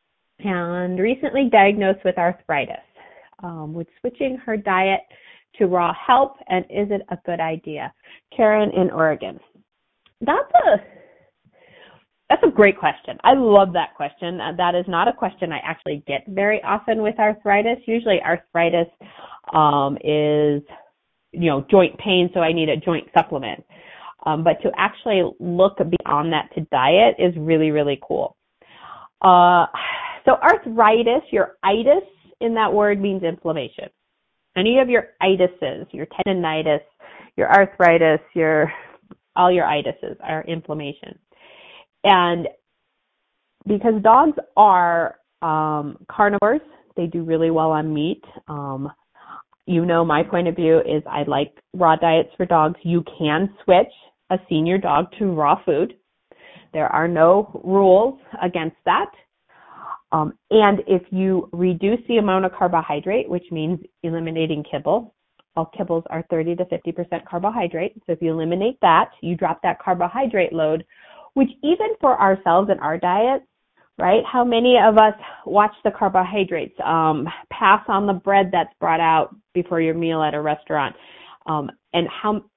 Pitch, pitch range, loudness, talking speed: 180 Hz, 160-205 Hz, -19 LUFS, 145 wpm